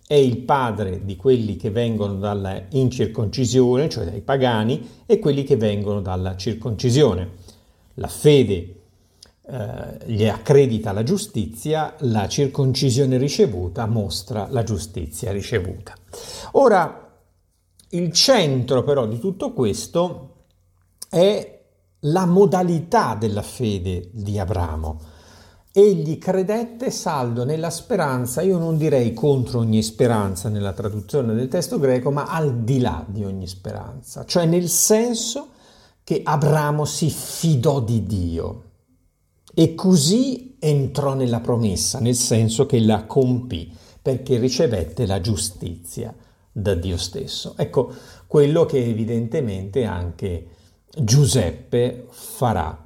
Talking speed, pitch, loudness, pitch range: 115 wpm, 120 Hz, -20 LUFS, 100-145 Hz